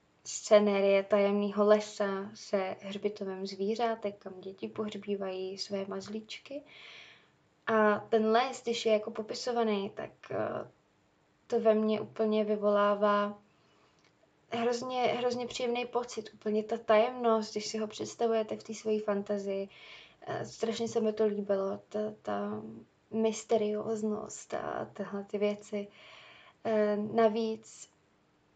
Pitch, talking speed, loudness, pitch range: 215 Hz, 110 wpm, -32 LUFS, 205-225 Hz